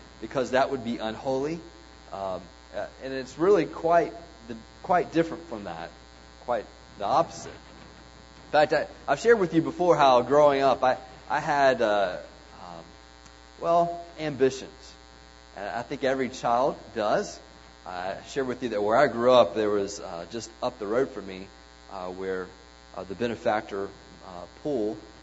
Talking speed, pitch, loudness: 160 wpm, 100 Hz, -26 LUFS